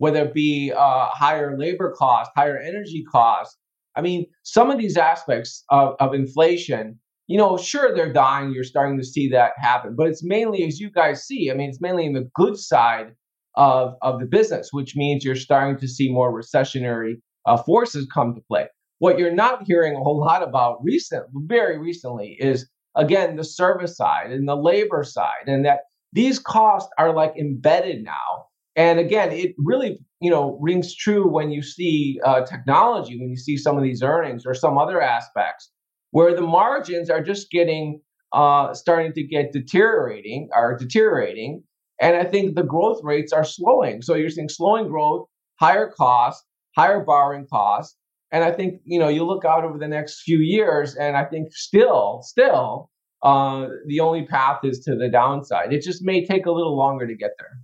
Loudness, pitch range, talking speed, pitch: -20 LUFS, 135-175 Hz, 190 wpm, 150 Hz